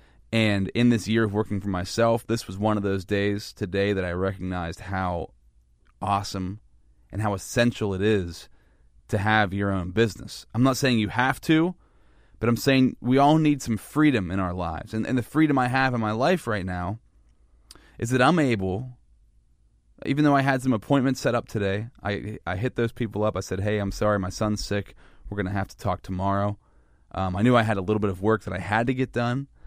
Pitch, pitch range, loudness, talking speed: 105 Hz, 95-120 Hz, -25 LUFS, 220 wpm